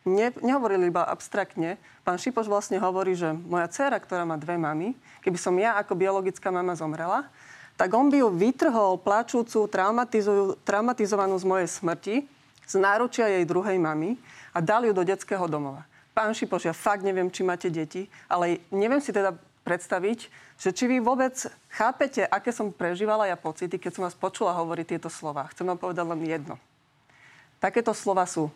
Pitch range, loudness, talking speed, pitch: 175-215 Hz, -26 LUFS, 170 wpm, 190 Hz